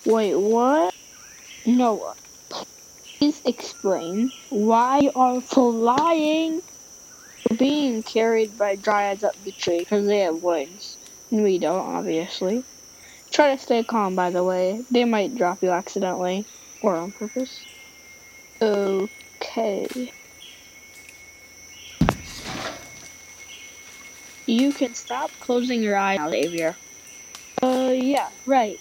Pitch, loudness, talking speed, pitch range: 225 Hz, -23 LUFS, 110 wpm, 195-255 Hz